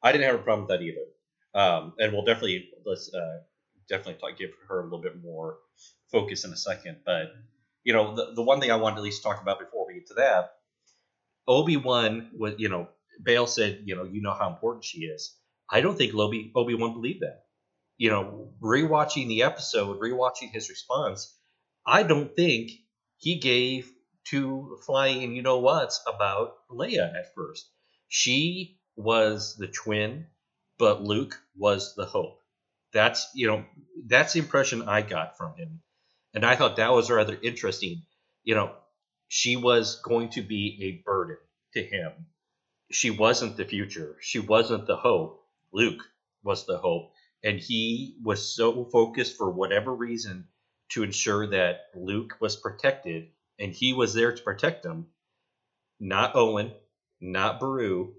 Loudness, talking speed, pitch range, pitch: -26 LUFS, 165 wpm, 110-155 Hz, 120 Hz